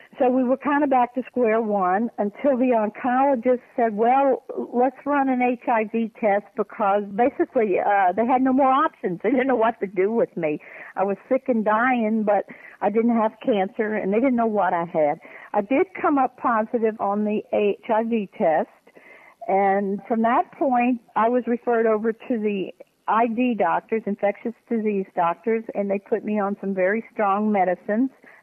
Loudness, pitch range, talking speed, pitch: -22 LUFS, 200-250 Hz, 180 wpm, 225 Hz